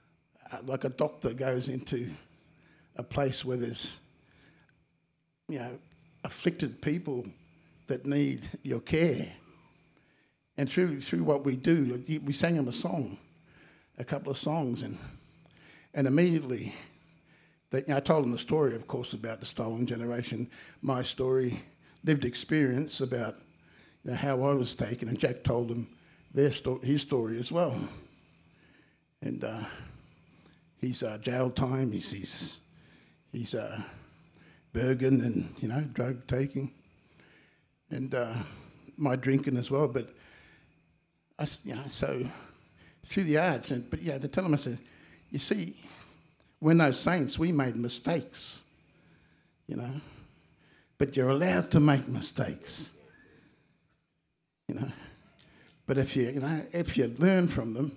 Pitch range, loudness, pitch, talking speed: 125-150 Hz, -31 LUFS, 135 Hz, 140 wpm